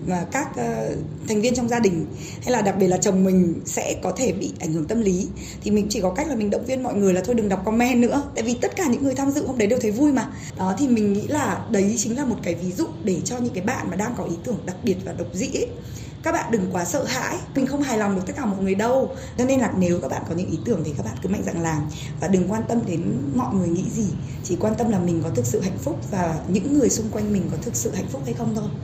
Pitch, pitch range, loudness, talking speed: 200 Hz, 175-240 Hz, -23 LUFS, 310 wpm